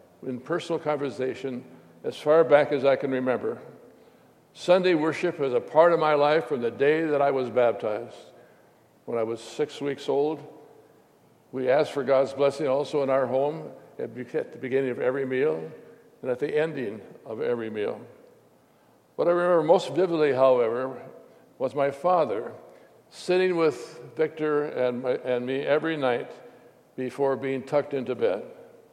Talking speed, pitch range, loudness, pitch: 160 wpm, 130-160 Hz, -25 LUFS, 145 Hz